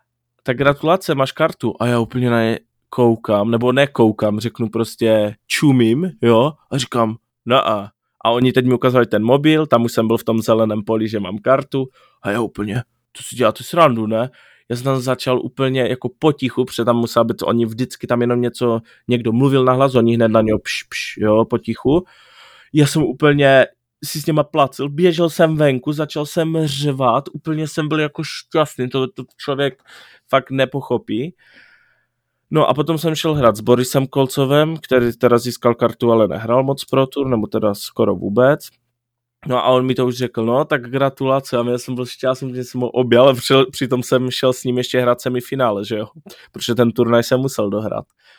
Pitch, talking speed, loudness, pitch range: 125 Hz, 190 wpm, -17 LUFS, 115-135 Hz